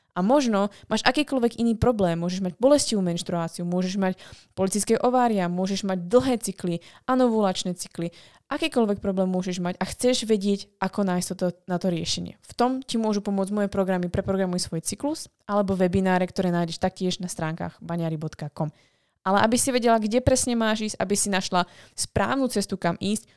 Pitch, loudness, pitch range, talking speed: 195 Hz, -25 LUFS, 180-220 Hz, 170 wpm